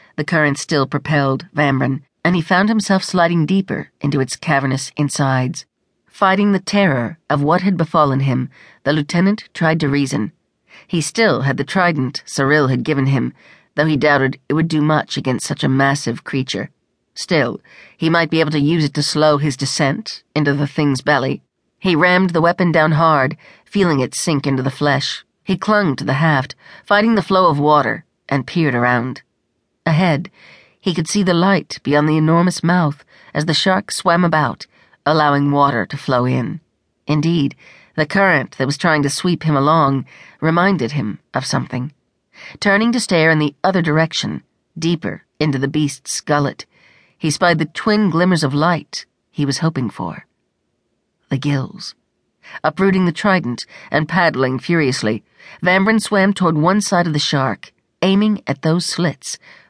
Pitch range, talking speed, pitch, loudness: 140-175 Hz, 170 wpm, 155 Hz, -17 LUFS